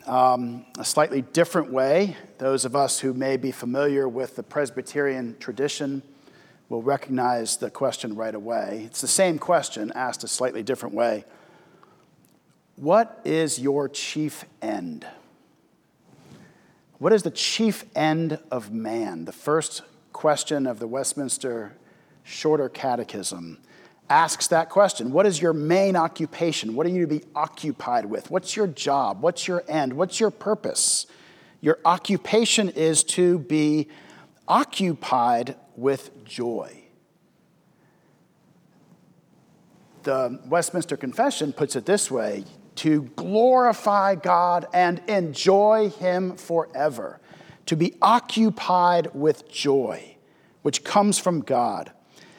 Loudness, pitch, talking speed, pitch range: -23 LUFS, 155 Hz, 120 wpm, 135-180 Hz